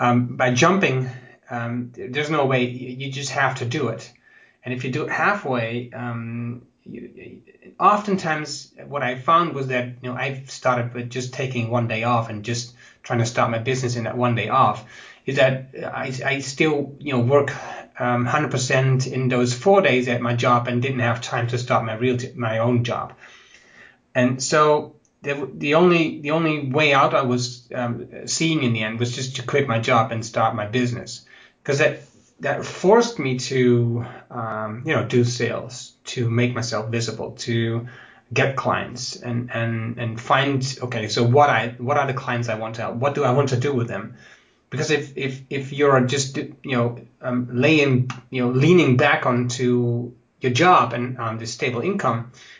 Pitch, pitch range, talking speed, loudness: 125 Hz, 120-135 Hz, 195 wpm, -21 LUFS